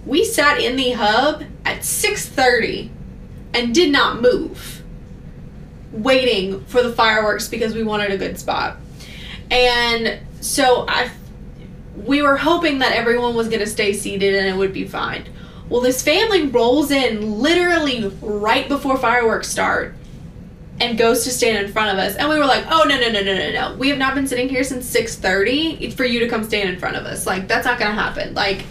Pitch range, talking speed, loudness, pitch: 220-280 Hz, 190 wpm, -17 LUFS, 245 Hz